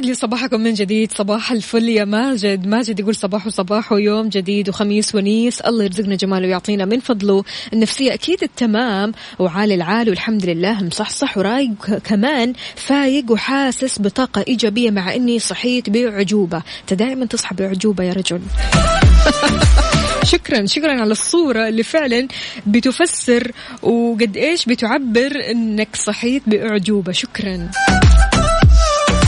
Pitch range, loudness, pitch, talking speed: 205-245 Hz, -16 LUFS, 220 Hz, 125 wpm